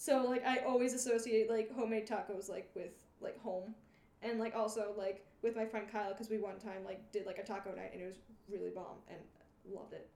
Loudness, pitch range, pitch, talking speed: -40 LUFS, 195-230 Hz, 220 Hz, 225 wpm